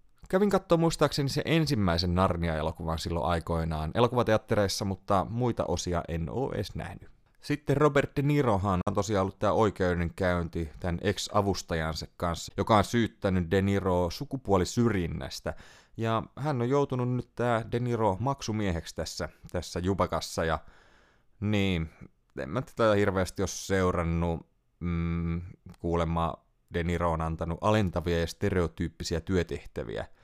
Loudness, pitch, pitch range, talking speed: -29 LUFS, 95 Hz, 85-115 Hz, 125 wpm